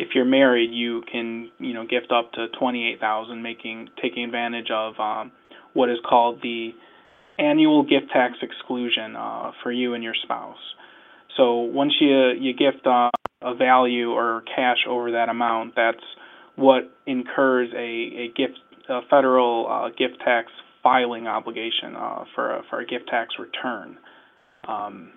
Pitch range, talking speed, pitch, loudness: 115-125 Hz, 155 wpm, 120 Hz, -22 LUFS